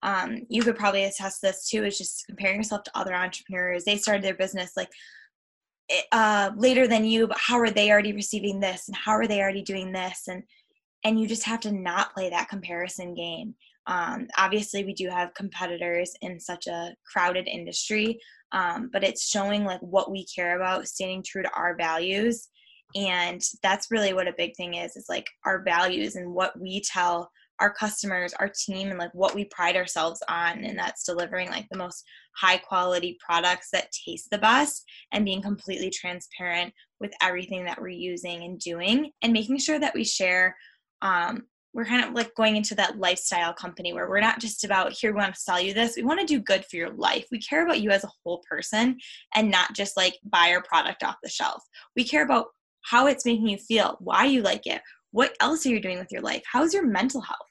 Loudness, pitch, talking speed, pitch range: -26 LUFS, 195 Hz, 210 wpm, 180-220 Hz